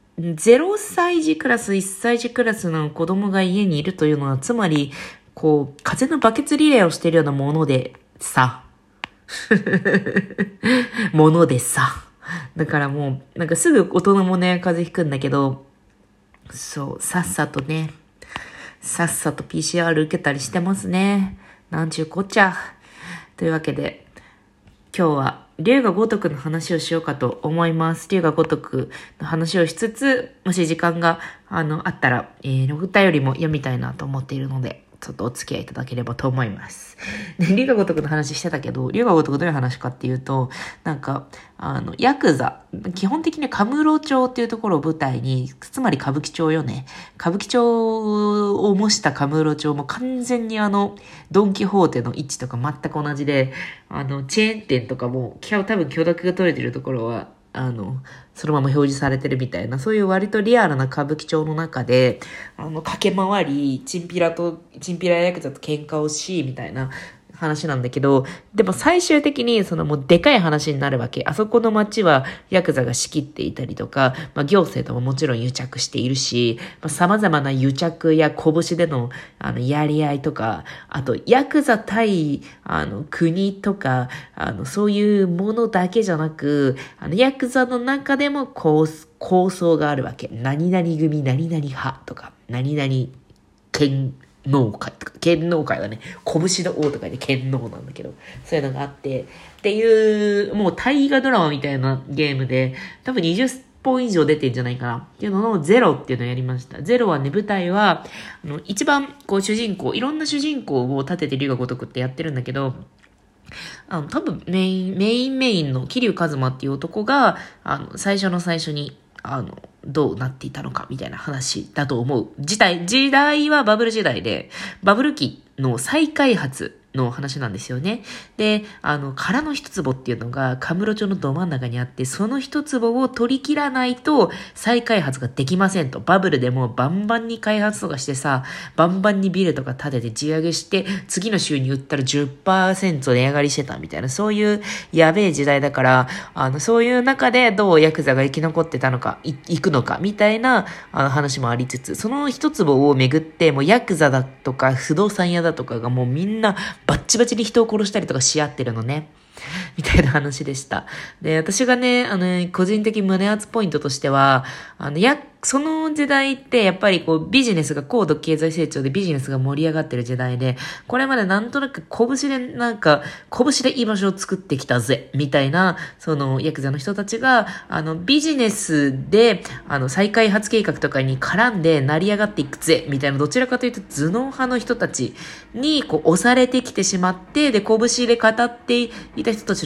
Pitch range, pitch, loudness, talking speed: 140-210 Hz, 165 Hz, -20 LUFS, 345 characters per minute